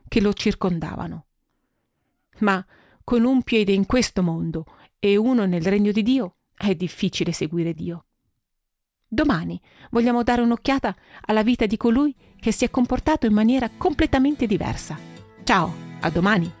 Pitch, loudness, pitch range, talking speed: 215 Hz, -22 LUFS, 180-245 Hz, 140 wpm